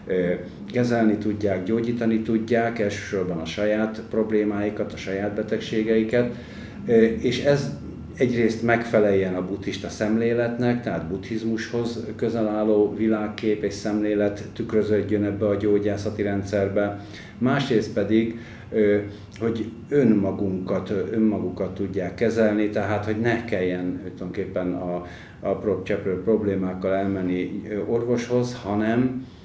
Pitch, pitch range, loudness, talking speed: 105 Hz, 100-115 Hz, -24 LUFS, 100 wpm